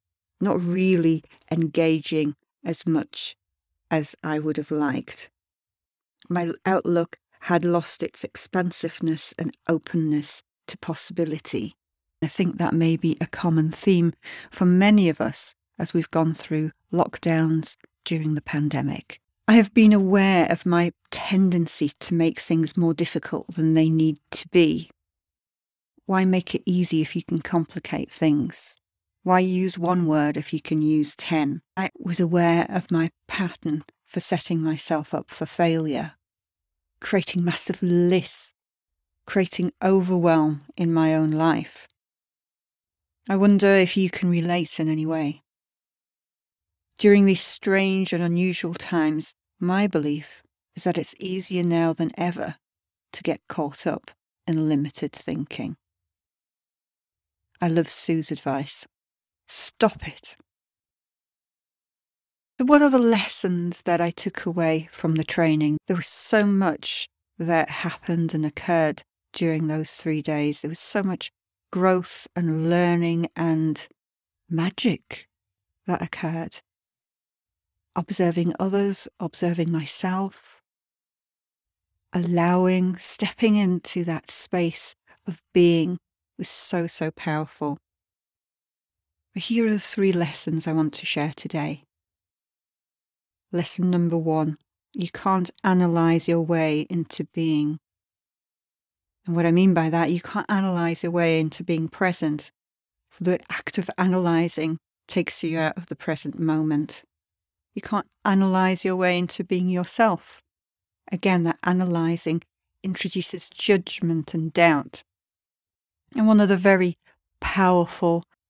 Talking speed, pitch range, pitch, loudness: 125 wpm, 155-180 Hz, 165 Hz, -23 LUFS